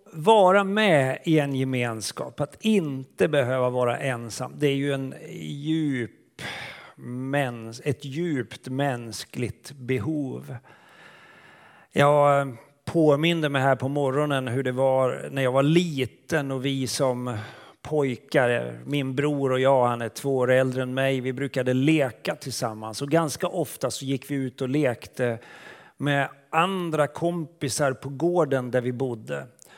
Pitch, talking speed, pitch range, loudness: 135 Hz, 135 wpm, 125-145 Hz, -25 LUFS